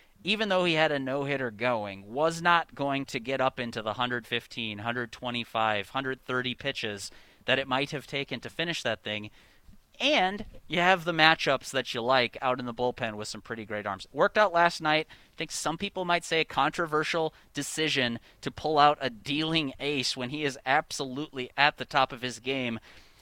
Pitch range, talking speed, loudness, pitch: 120-155 Hz, 190 wpm, -28 LUFS, 135 Hz